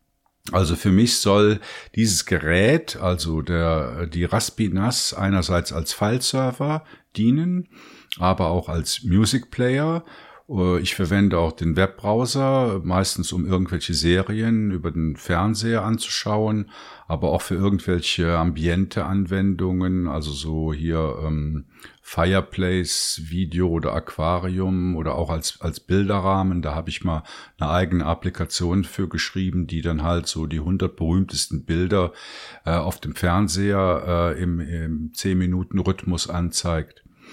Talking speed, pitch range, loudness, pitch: 125 wpm, 85-100 Hz, -22 LUFS, 90 Hz